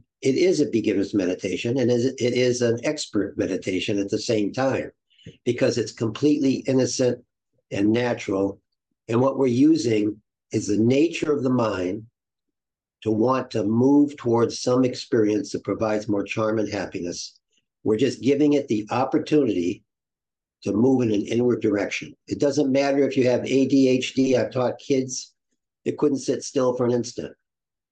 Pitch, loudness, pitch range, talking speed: 125 Hz, -23 LUFS, 110-135 Hz, 155 wpm